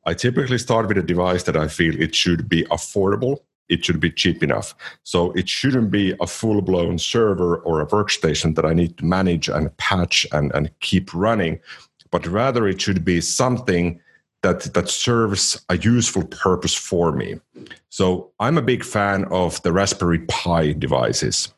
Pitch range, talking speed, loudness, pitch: 85-105 Hz, 180 wpm, -20 LUFS, 90 Hz